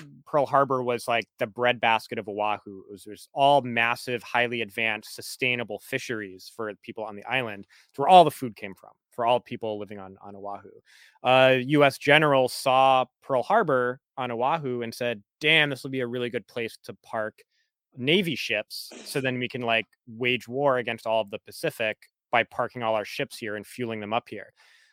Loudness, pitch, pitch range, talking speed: -25 LUFS, 120 Hz, 110-130 Hz, 195 wpm